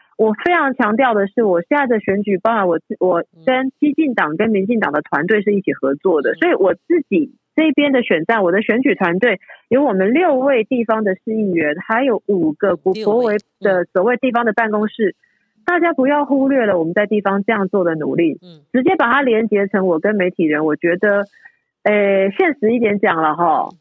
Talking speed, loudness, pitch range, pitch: 295 characters per minute, -16 LUFS, 190-260 Hz, 215 Hz